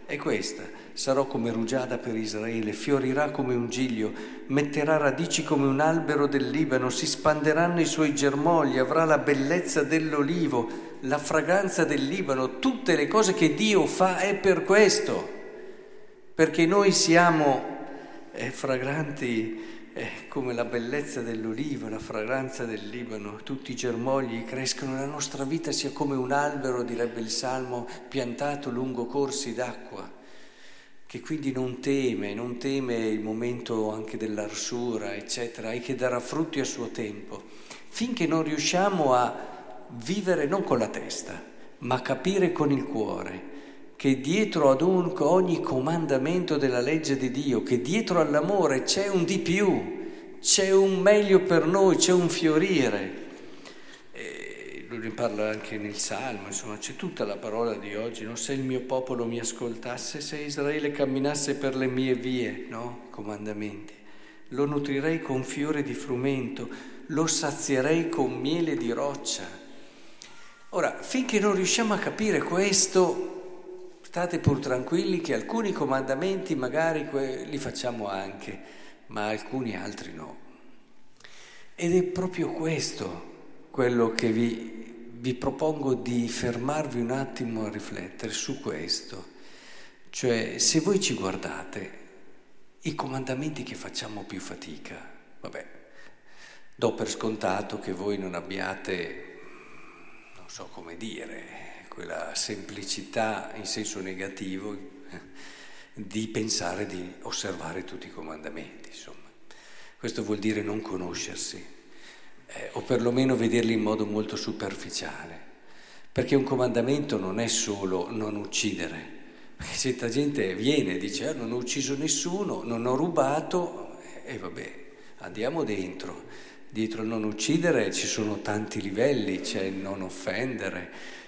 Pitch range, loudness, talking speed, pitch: 115-160 Hz, -27 LUFS, 135 wpm, 135 Hz